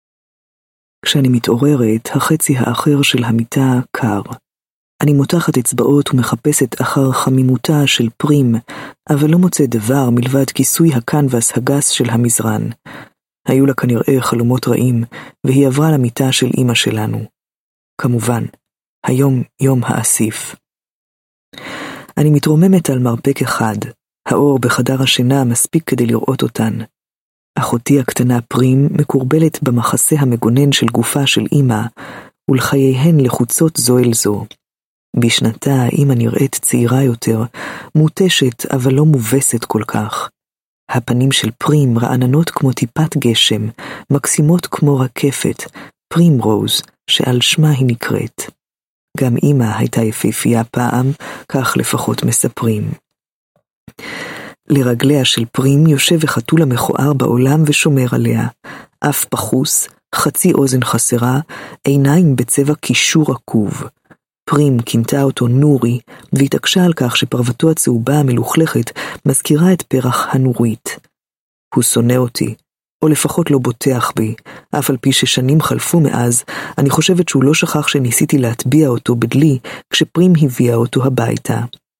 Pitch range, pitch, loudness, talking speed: 120-145 Hz, 130 Hz, -13 LUFS, 120 wpm